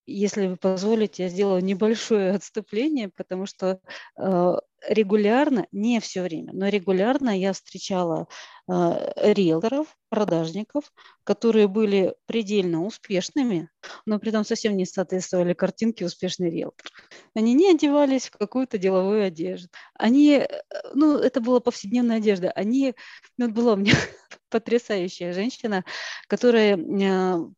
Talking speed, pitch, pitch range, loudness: 120 wpm, 205 Hz, 185-235 Hz, -23 LUFS